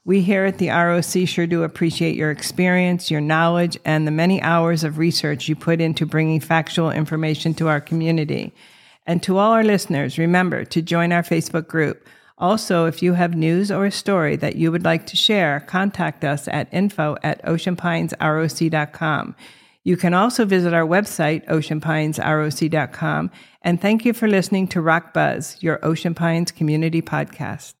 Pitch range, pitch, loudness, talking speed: 155-180 Hz, 165 Hz, -19 LUFS, 170 wpm